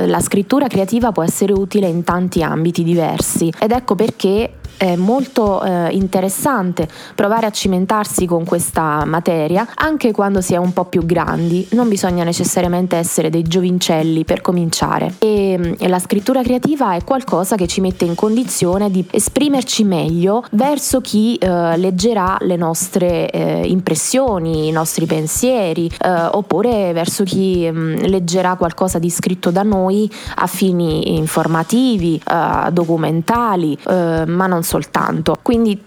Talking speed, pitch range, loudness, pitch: 145 wpm, 170-210 Hz, -16 LUFS, 185 Hz